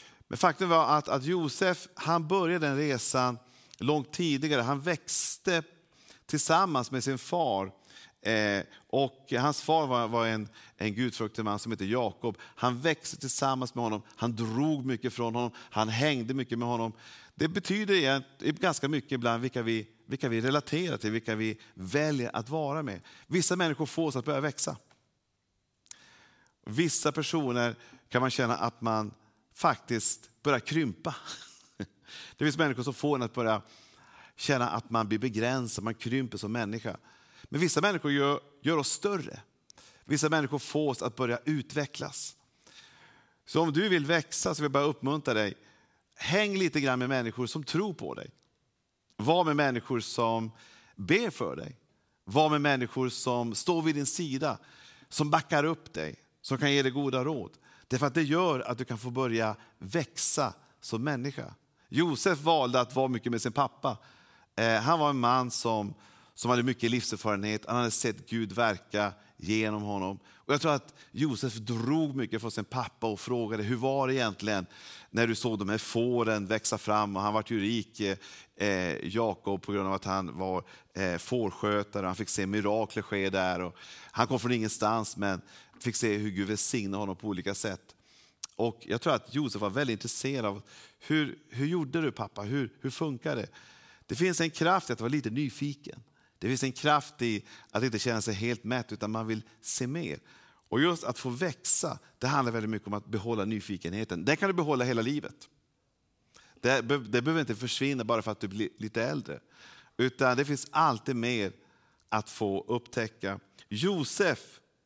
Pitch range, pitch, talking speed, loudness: 110-145 Hz, 125 Hz, 175 wpm, -30 LUFS